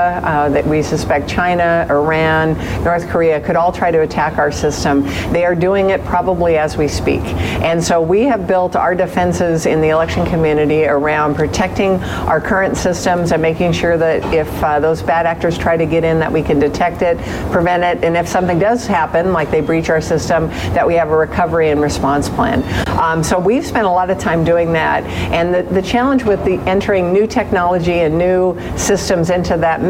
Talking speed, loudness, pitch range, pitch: 205 wpm, -14 LUFS, 155-180 Hz, 170 Hz